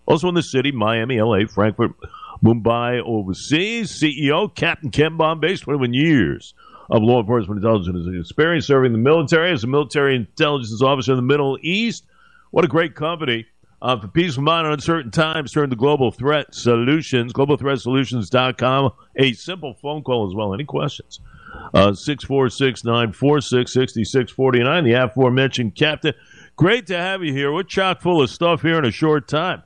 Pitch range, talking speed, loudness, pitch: 120-155 Hz, 160 wpm, -19 LUFS, 135 Hz